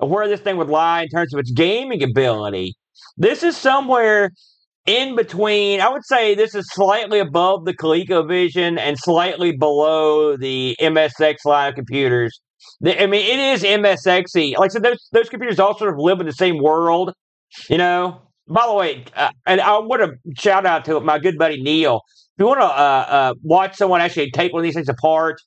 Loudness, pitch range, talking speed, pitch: -17 LUFS, 155-200 Hz, 200 wpm, 175 Hz